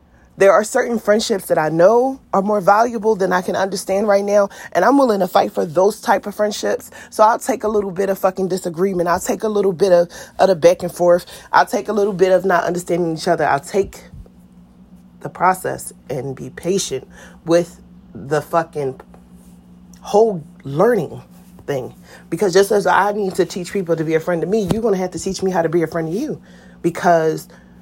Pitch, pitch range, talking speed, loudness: 185 Hz, 165-200 Hz, 210 wpm, -17 LUFS